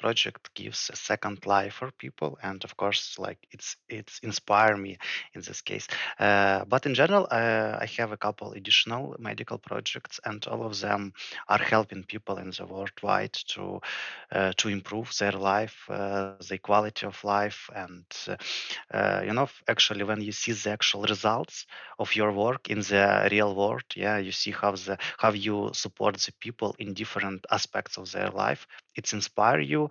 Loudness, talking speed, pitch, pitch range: -28 LUFS, 180 wpm, 105 Hz, 100-110 Hz